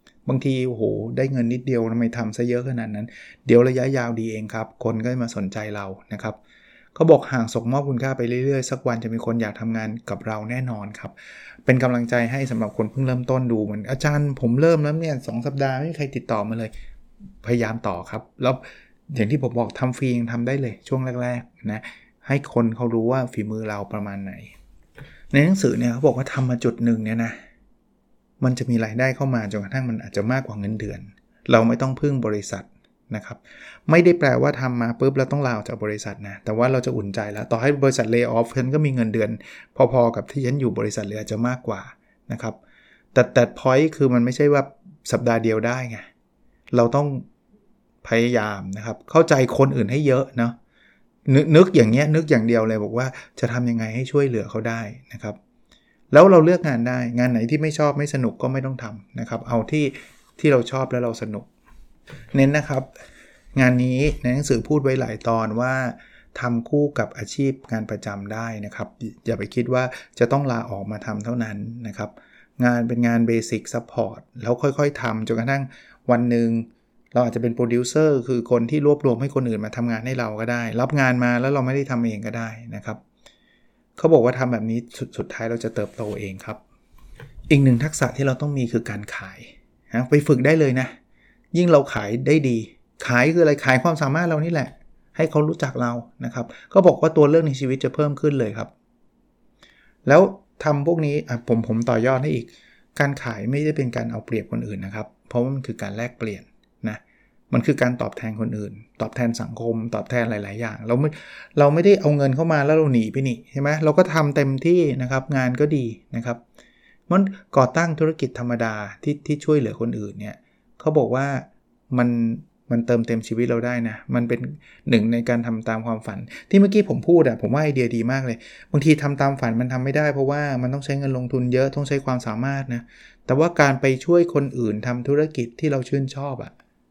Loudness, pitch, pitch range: -21 LUFS, 125 Hz, 115-140 Hz